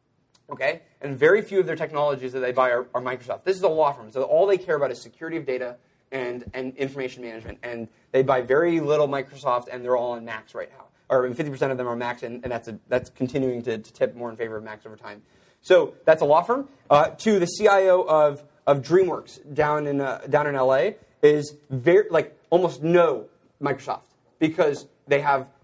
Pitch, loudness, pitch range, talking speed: 135 Hz, -23 LUFS, 125-155 Hz, 220 wpm